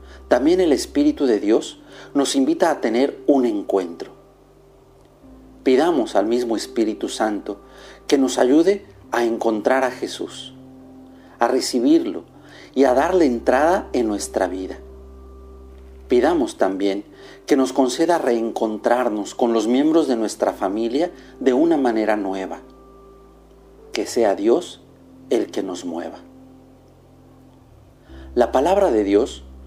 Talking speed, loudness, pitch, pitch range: 120 wpm, -20 LUFS, 120 Hz, 95-145 Hz